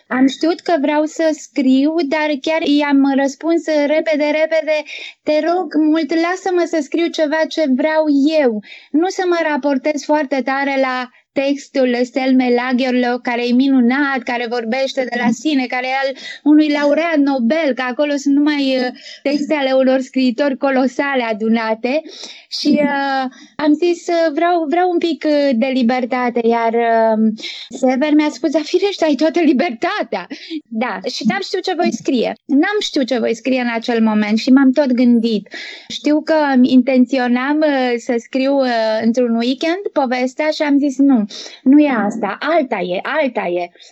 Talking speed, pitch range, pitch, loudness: 155 wpm, 250-310 Hz, 275 Hz, -16 LUFS